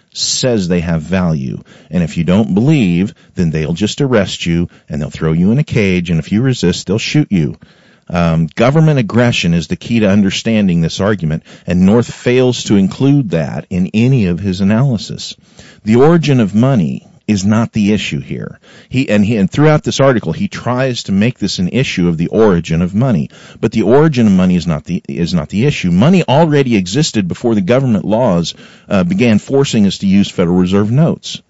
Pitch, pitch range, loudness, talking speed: 115 Hz, 95-145 Hz, -13 LUFS, 200 wpm